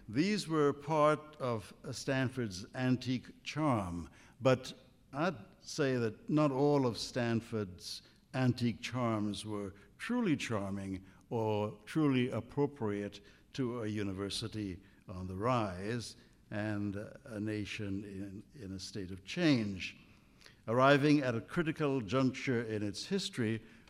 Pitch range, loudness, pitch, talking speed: 105-135 Hz, -35 LUFS, 115 Hz, 115 wpm